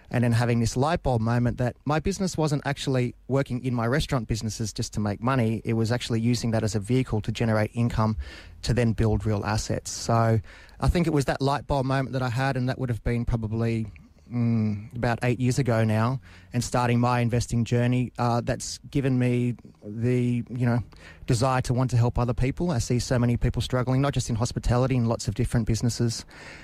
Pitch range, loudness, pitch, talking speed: 115-125 Hz, -26 LUFS, 120 Hz, 215 wpm